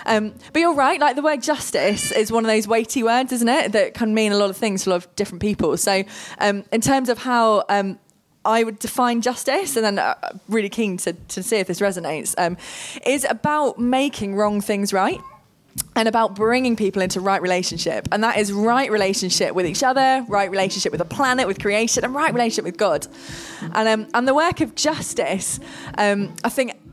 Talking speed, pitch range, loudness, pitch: 210 wpm, 195-245 Hz, -20 LUFS, 220 Hz